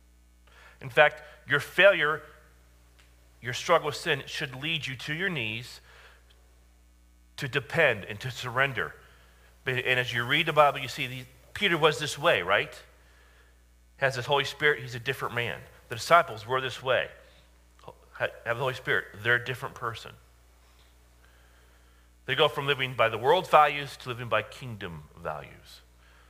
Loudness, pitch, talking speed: -27 LUFS, 115 Hz, 155 wpm